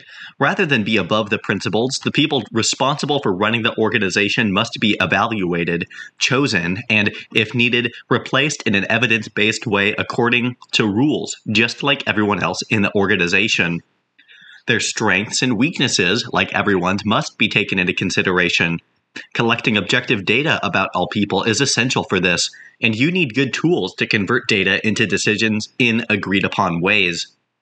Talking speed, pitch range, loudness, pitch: 155 wpm, 100-120 Hz, -17 LUFS, 110 Hz